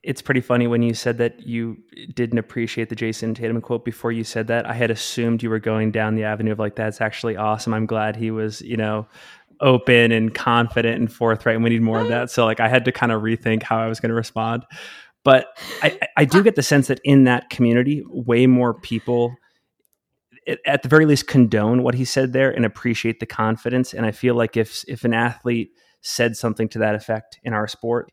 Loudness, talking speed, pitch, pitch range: -20 LUFS, 230 wpm, 115 Hz, 110-120 Hz